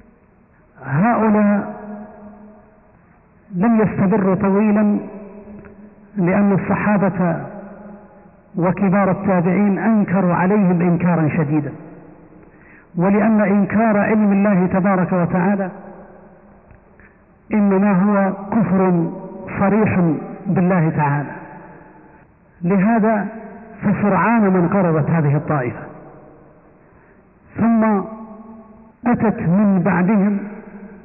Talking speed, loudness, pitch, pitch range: 65 wpm, -17 LUFS, 195 Hz, 175-210 Hz